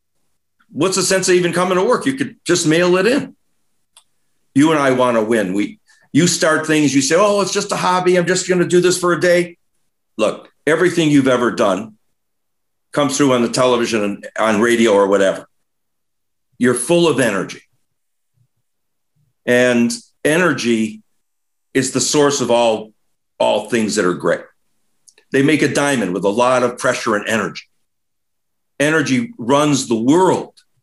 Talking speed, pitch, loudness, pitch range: 165 wpm, 135 Hz, -16 LUFS, 120-175 Hz